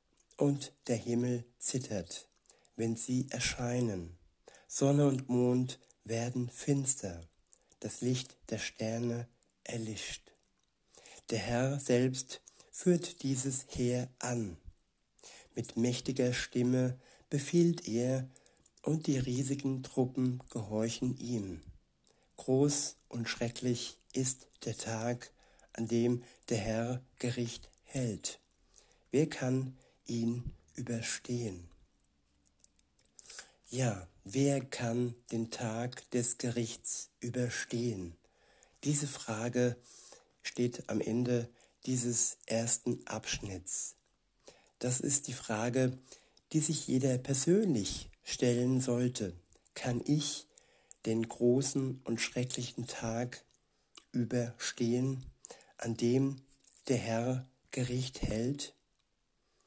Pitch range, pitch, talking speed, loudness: 115-130 Hz, 120 Hz, 90 wpm, -34 LUFS